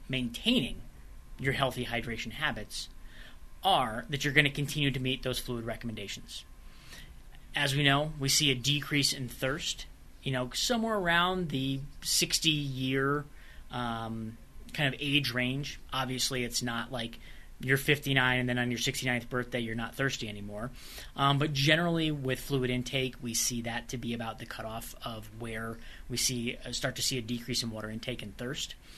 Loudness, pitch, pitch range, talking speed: -31 LUFS, 125 Hz, 115-140 Hz, 170 wpm